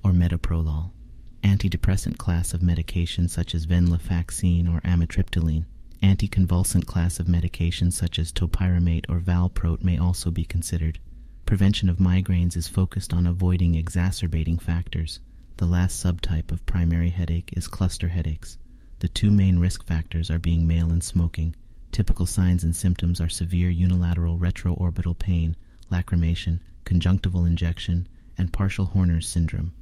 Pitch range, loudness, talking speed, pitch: 85-90 Hz, -24 LUFS, 135 wpm, 85 Hz